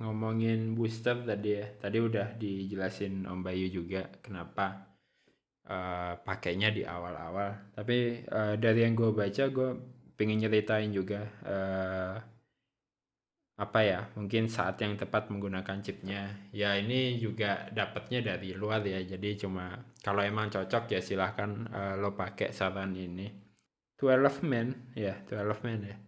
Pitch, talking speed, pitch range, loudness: 105 Hz, 140 wpm, 95-115 Hz, -33 LUFS